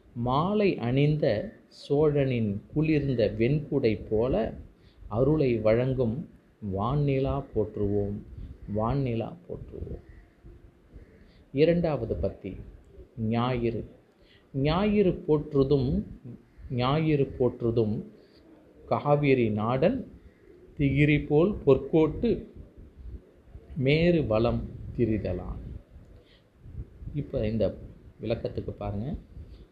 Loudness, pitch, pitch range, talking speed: -27 LUFS, 120 Hz, 105-145 Hz, 65 wpm